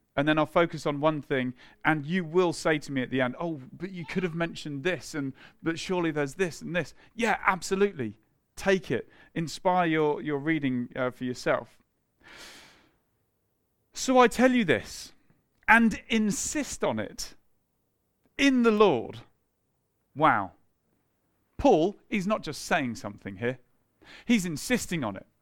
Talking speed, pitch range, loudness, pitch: 155 wpm, 135-195 Hz, -27 LUFS, 165 Hz